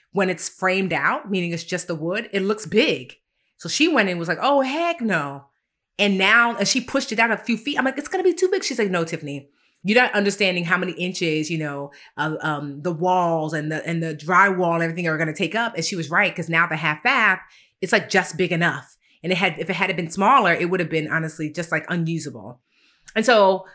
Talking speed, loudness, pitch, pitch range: 250 wpm, -21 LUFS, 180 Hz, 165-205 Hz